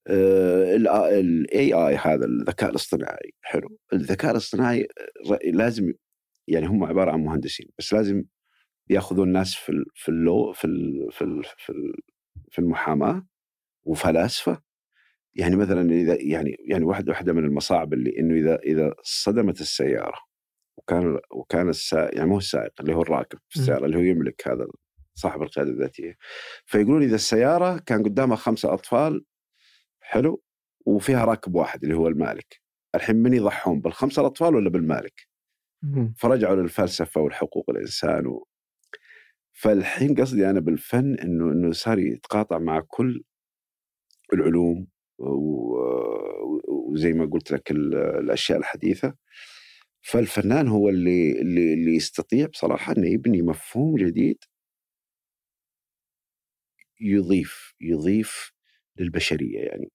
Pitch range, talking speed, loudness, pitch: 85-120 Hz, 115 wpm, -23 LUFS, 95 Hz